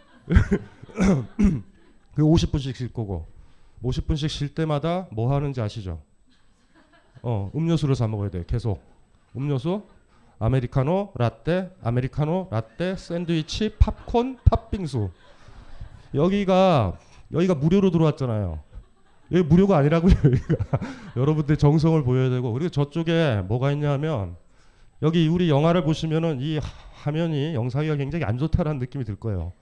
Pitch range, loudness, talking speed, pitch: 115-165 Hz, -23 LUFS, 290 characters per minute, 140 Hz